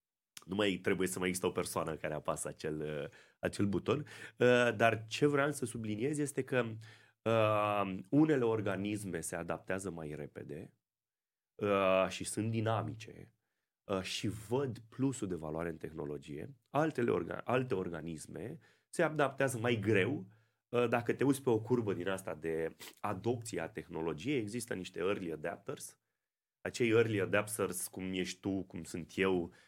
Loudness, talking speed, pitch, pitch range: -35 LUFS, 135 wpm, 105 Hz, 90-120 Hz